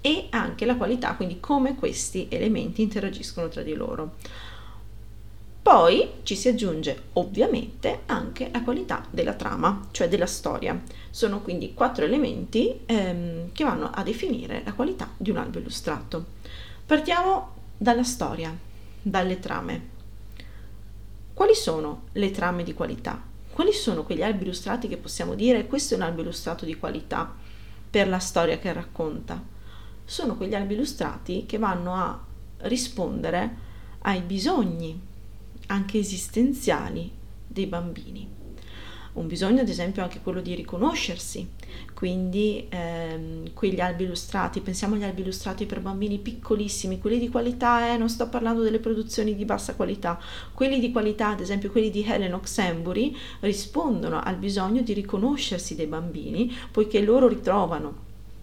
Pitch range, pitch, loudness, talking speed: 165-230 Hz, 195 Hz, -26 LUFS, 140 wpm